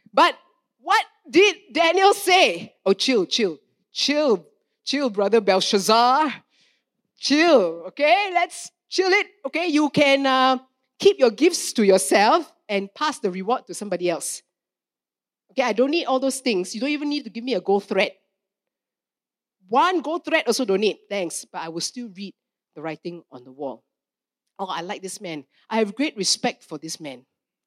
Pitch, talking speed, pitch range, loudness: 250 Hz, 170 wpm, 195-315 Hz, -21 LUFS